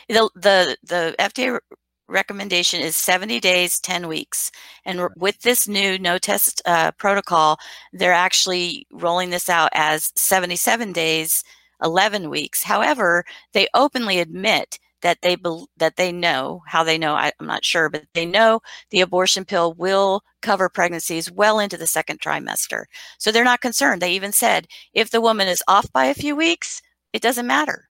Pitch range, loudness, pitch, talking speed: 170-220 Hz, -19 LUFS, 185 Hz, 170 wpm